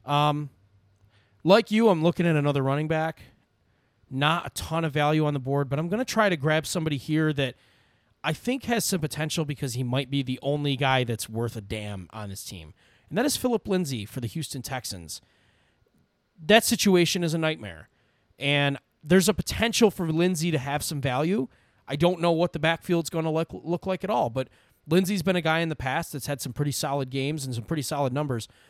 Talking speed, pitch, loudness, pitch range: 210 wpm, 145 Hz, -26 LUFS, 125-170 Hz